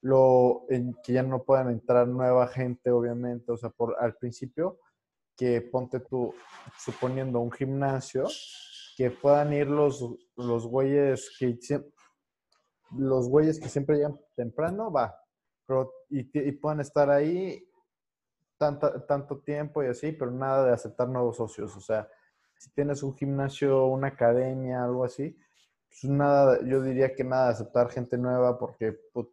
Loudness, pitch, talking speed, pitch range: -28 LUFS, 130 Hz, 150 wpm, 125-145 Hz